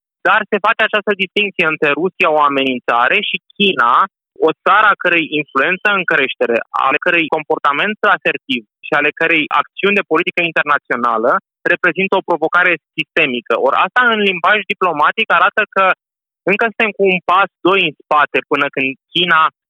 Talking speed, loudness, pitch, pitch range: 155 wpm, -14 LUFS, 180 Hz, 155-200 Hz